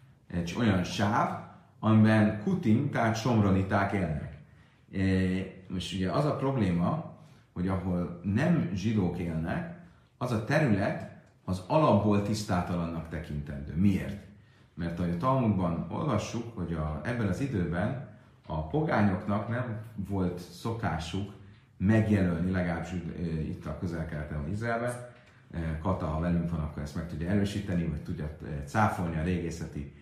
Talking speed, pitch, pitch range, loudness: 125 wpm, 95 Hz, 85-110 Hz, -30 LUFS